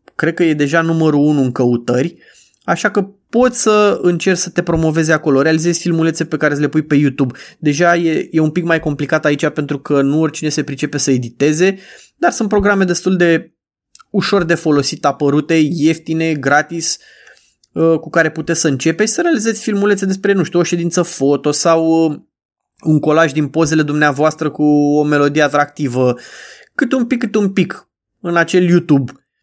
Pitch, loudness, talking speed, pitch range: 160 Hz, -14 LUFS, 175 wpm, 150-175 Hz